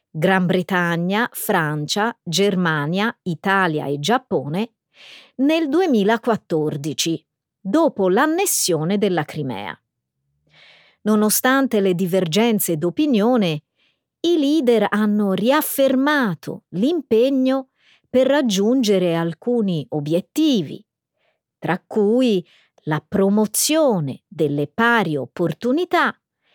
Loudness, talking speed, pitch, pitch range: -19 LUFS, 75 wpm, 205 Hz, 170-250 Hz